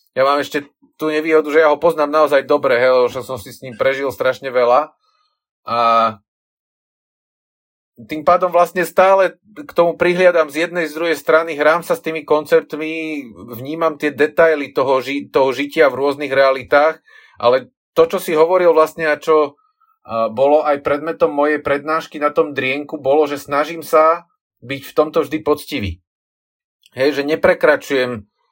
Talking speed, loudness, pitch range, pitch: 160 wpm, -16 LUFS, 140-165 Hz, 155 Hz